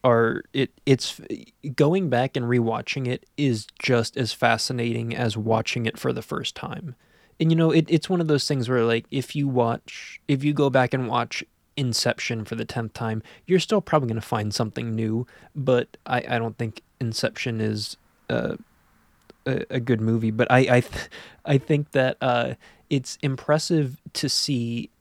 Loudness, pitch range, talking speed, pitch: -24 LUFS, 115-140 Hz, 180 wpm, 125 Hz